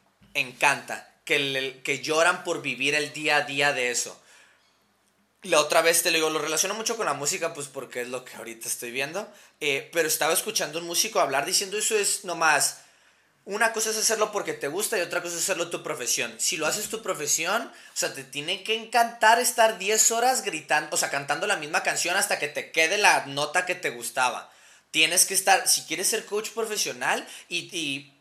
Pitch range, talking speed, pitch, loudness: 145-205 Hz, 210 wpm, 165 Hz, -24 LUFS